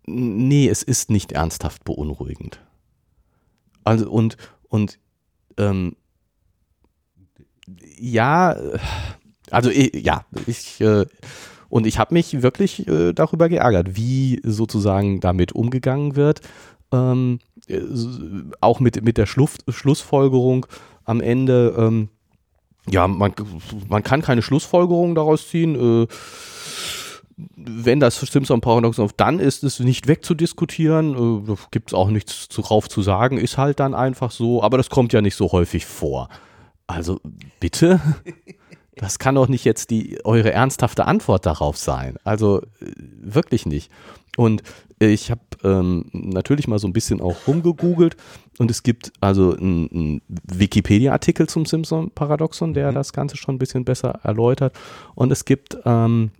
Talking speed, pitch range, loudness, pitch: 135 wpm, 100-135 Hz, -19 LUFS, 115 Hz